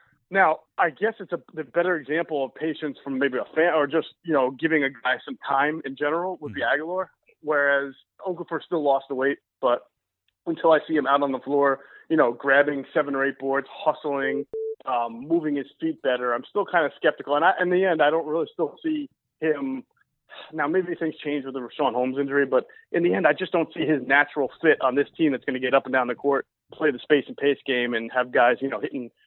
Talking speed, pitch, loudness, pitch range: 240 wpm, 145 Hz, -24 LUFS, 135-165 Hz